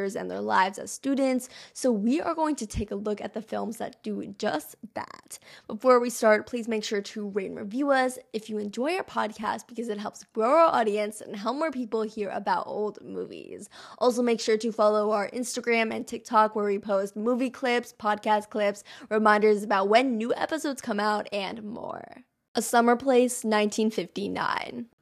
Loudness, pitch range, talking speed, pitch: -27 LUFS, 210-250 Hz, 190 wpm, 225 Hz